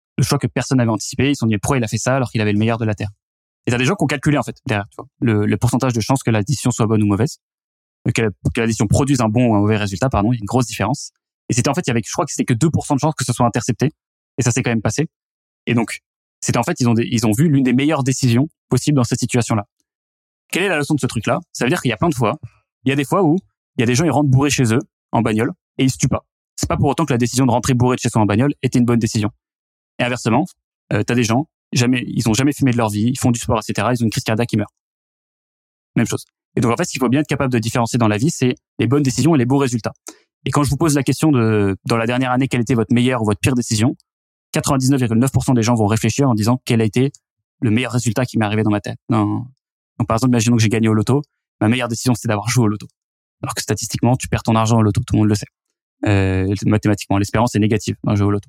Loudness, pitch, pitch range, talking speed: -18 LUFS, 120 Hz, 110-135 Hz, 300 wpm